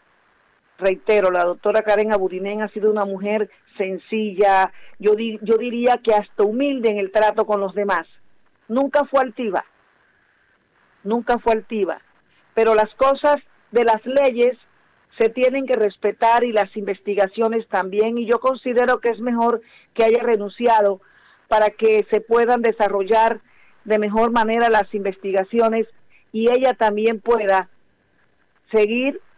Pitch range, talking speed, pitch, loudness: 205-235 Hz, 135 wpm, 220 Hz, -19 LUFS